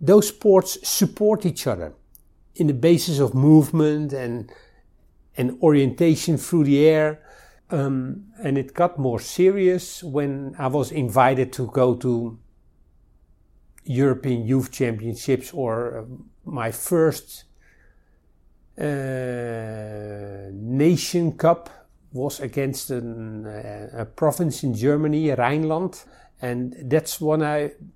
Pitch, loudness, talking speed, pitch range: 135 Hz, -21 LUFS, 110 wpm, 115-155 Hz